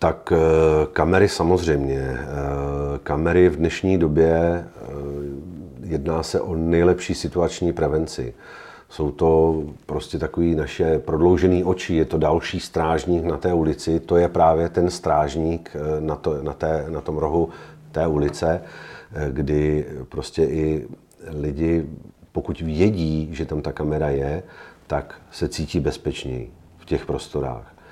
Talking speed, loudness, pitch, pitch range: 125 wpm, -22 LUFS, 80 Hz, 75-85 Hz